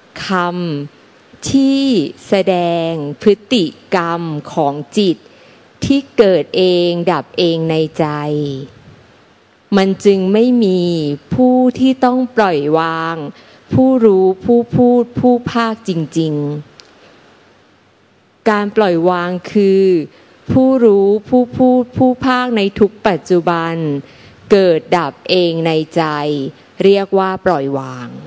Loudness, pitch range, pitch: -14 LUFS, 160-220 Hz, 180 Hz